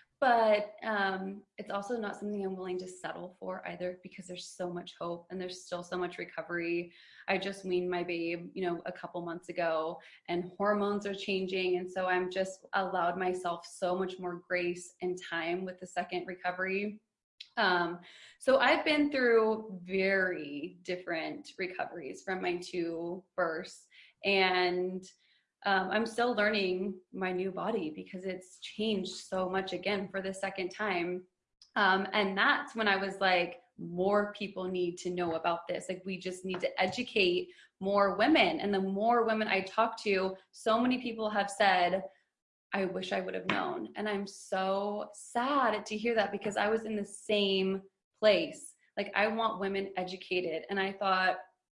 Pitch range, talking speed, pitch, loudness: 180-205 Hz, 170 wpm, 190 Hz, -32 LUFS